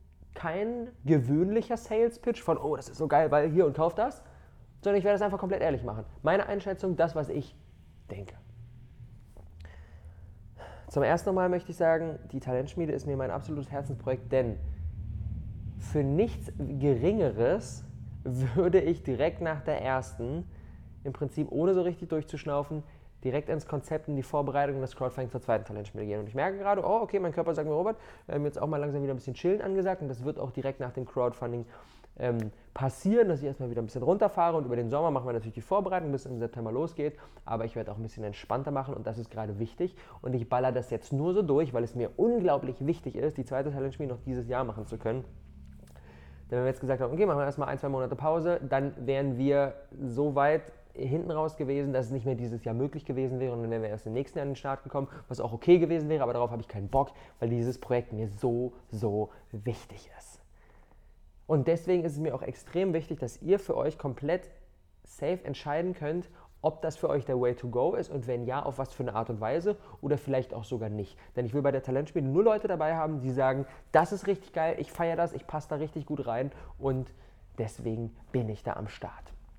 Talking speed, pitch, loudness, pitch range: 220 wpm, 135 Hz, -31 LUFS, 115-155 Hz